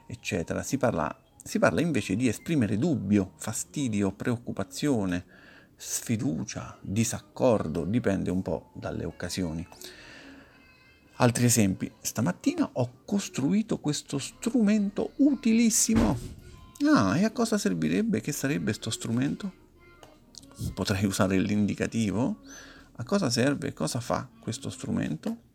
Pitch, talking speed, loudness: 125 Hz, 110 wpm, -28 LUFS